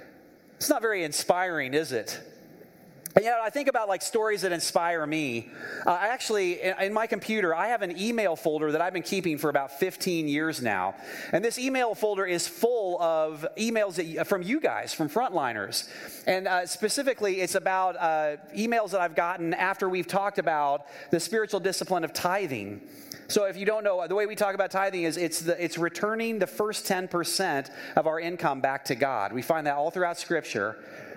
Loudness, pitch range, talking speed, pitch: -28 LUFS, 160-205 Hz, 195 wpm, 185 Hz